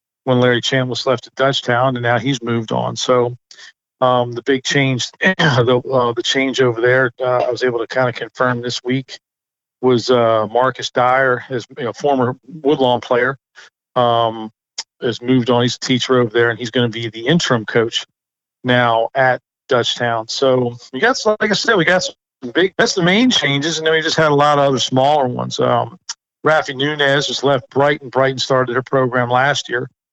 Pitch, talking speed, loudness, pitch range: 130 Hz, 200 wpm, -16 LUFS, 120-140 Hz